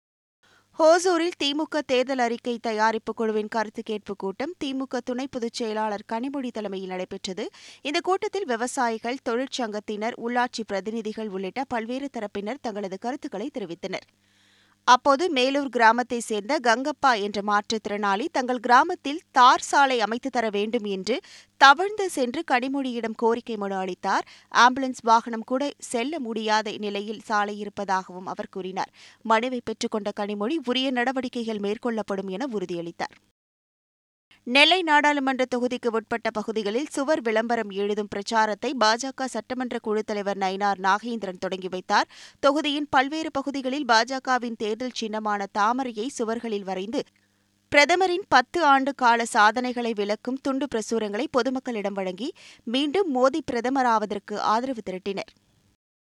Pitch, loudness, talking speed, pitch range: 235 Hz, -25 LUFS, 115 wpm, 210-265 Hz